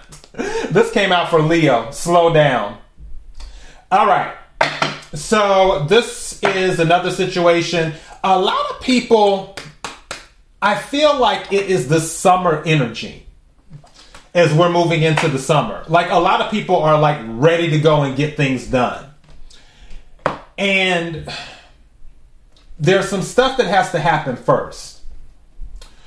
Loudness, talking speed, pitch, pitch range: -16 LUFS, 125 wpm, 170 Hz, 150-190 Hz